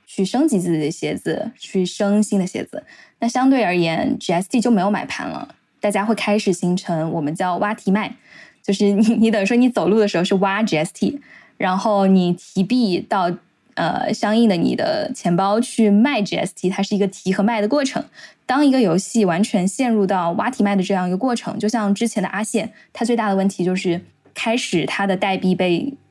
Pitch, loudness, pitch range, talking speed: 205 Hz, -19 LUFS, 185-230 Hz, 300 characters per minute